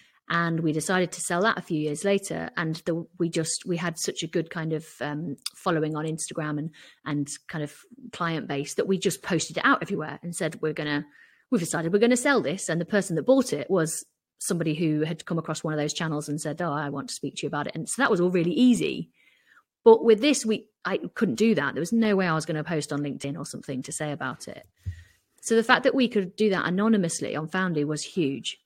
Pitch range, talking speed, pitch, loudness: 150-200 Hz, 255 wpm, 165 Hz, -26 LUFS